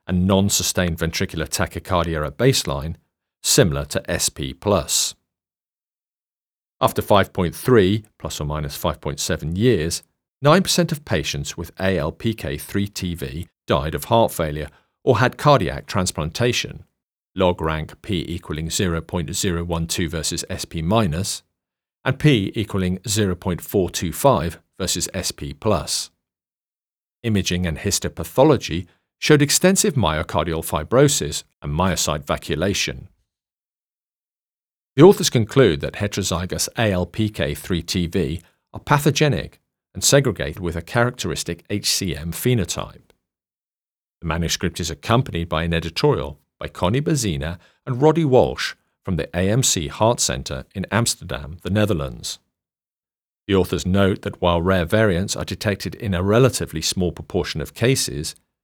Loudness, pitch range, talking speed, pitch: -20 LUFS, 80-105 Hz, 110 wpm, 90 Hz